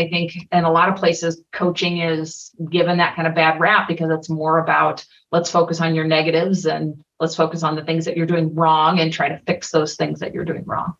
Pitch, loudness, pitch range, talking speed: 165 Hz, -19 LUFS, 160-170 Hz, 240 wpm